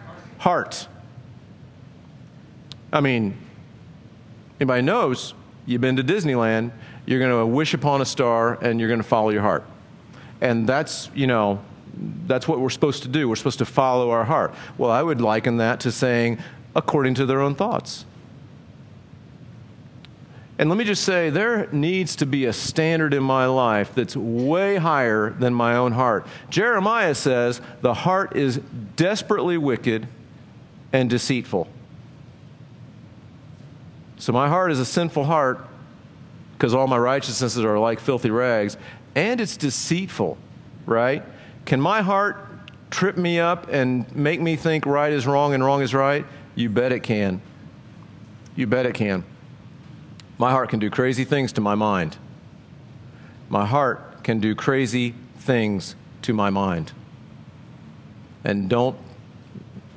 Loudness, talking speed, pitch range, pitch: -22 LUFS, 145 wpm, 120-145 Hz, 130 Hz